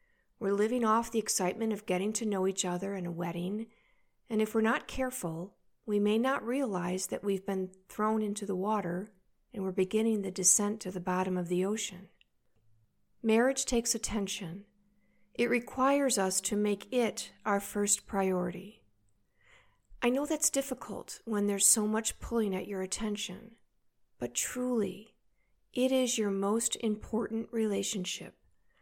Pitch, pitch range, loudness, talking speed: 205 Hz, 185-225 Hz, -31 LUFS, 150 wpm